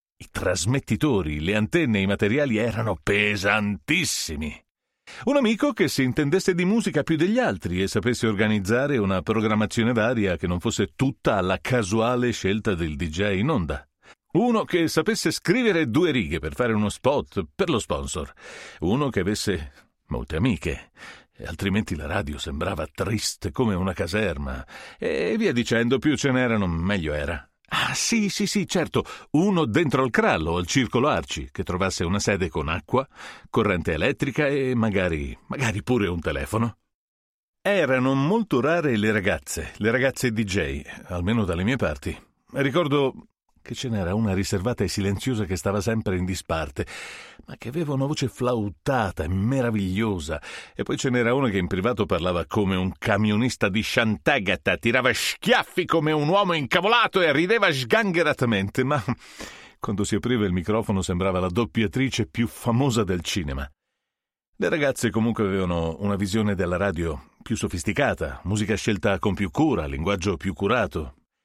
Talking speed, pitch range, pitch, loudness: 155 wpm, 95-130 Hz, 110 Hz, -24 LUFS